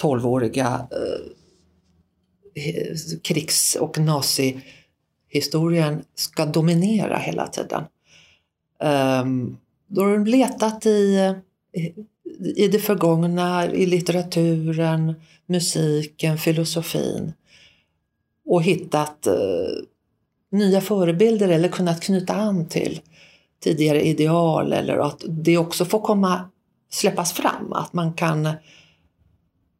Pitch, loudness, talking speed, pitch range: 165 Hz, -21 LUFS, 95 wpm, 150-190 Hz